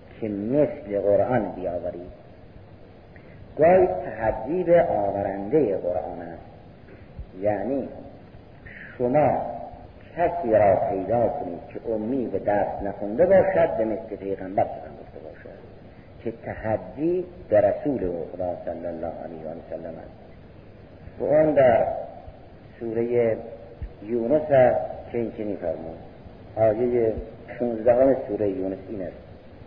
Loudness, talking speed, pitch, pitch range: -24 LUFS, 105 wpm, 105 Hz, 95-120 Hz